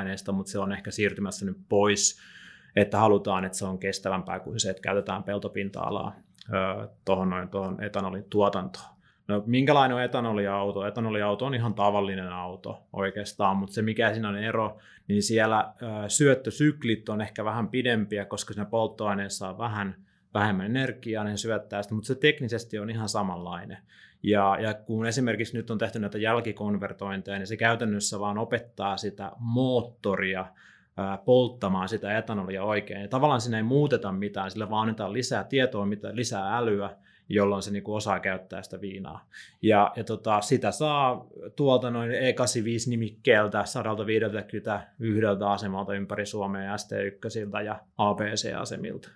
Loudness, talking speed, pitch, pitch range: -28 LUFS, 145 wpm, 105 Hz, 100-115 Hz